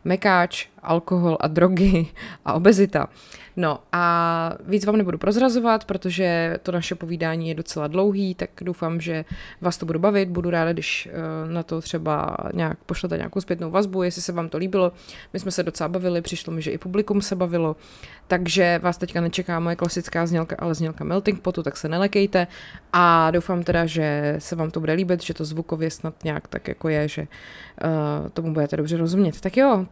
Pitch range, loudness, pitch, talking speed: 165-185 Hz, -23 LUFS, 175 Hz, 185 wpm